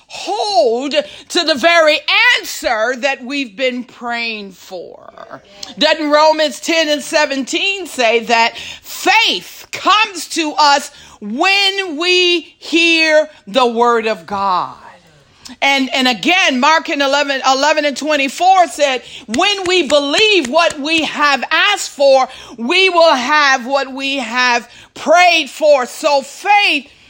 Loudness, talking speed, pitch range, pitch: -13 LUFS, 125 wpm, 265-335 Hz, 295 Hz